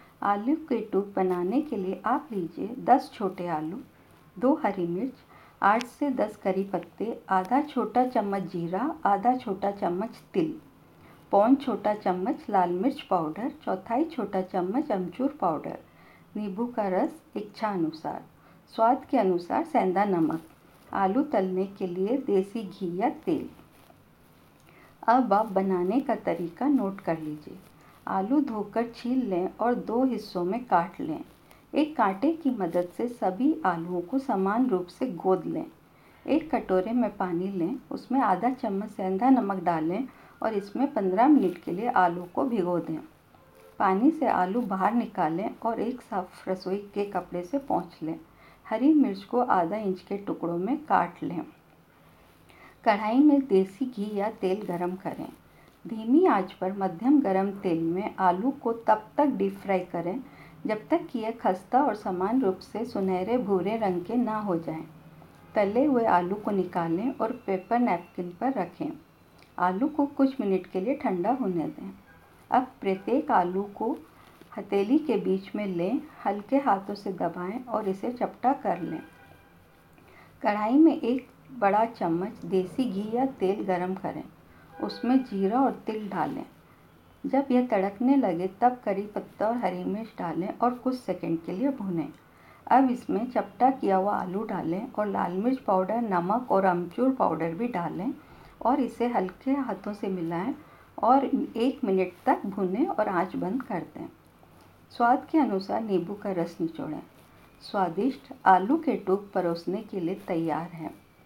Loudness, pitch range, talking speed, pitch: -27 LUFS, 185-250 Hz, 155 wpm, 205 Hz